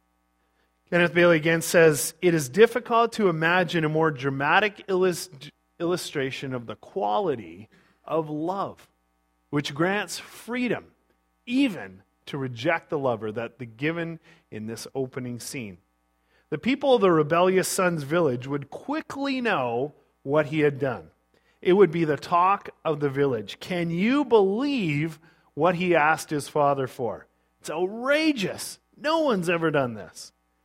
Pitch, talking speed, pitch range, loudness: 160 Hz, 140 wpm, 125-180 Hz, -24 LUFS